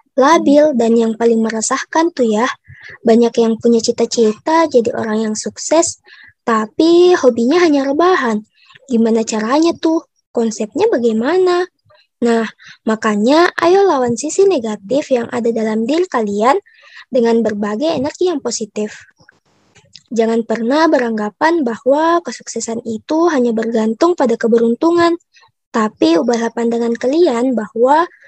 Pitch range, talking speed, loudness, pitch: 225-315 Hz, 115 wpm, -14 LUFS, 240 Hz